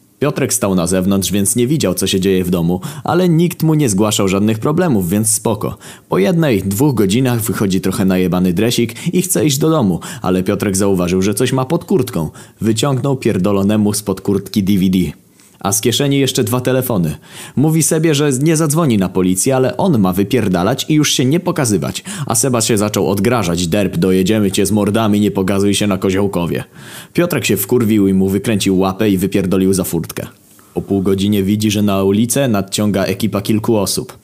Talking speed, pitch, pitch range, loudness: 190 wpm, 105 Hz, 95-130 Hz, -14 LUFS